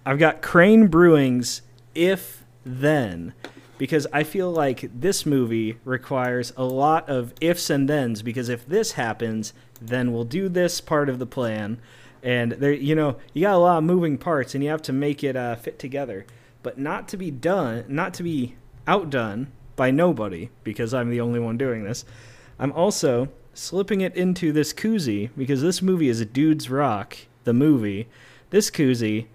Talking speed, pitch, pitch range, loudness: 180 wpm, 135 Hz, 120-155 Hz, -22 LUFS